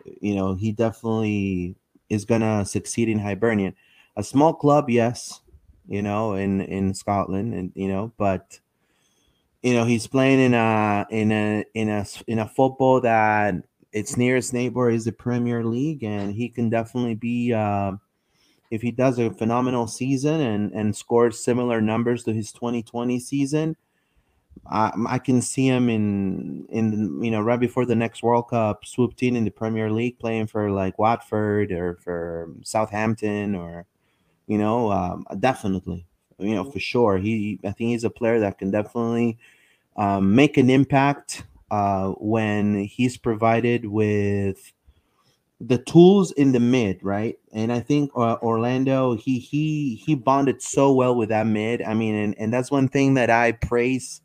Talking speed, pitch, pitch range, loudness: 165 wpm, 115 Hz, 105-120 Hz, -22 LUFS